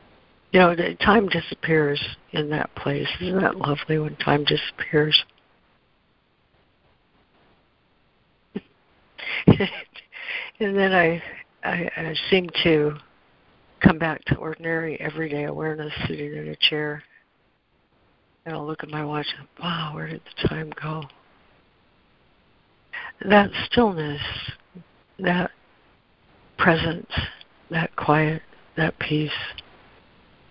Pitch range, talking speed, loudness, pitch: 150-175 Hz, 100 wpm, -23 LUFS, 155 Hz